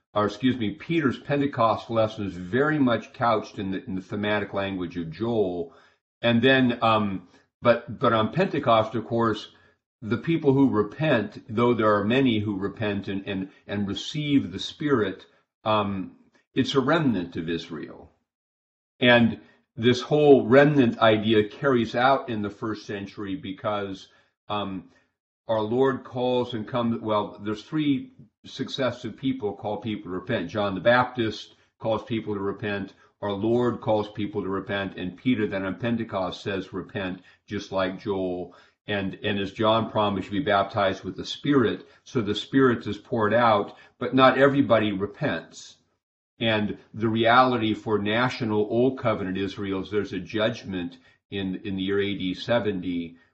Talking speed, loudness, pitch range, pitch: 155 wpm, -25 LUFS, 100-120 Hz, 105 Hz